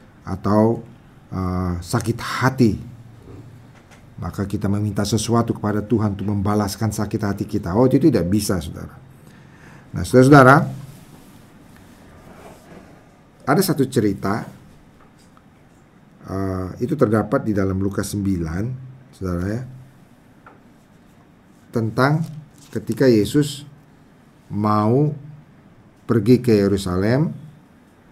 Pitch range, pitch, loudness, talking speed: 100-130 Hz, 110 Hz, -19 LUFS, 85 wpm